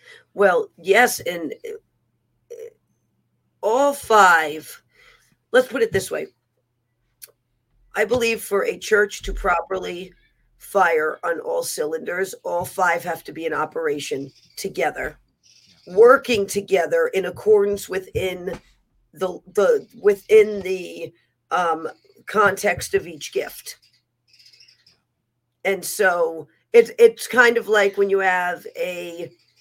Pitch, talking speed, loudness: 200 Hz, 110 wpm, -20 LUFS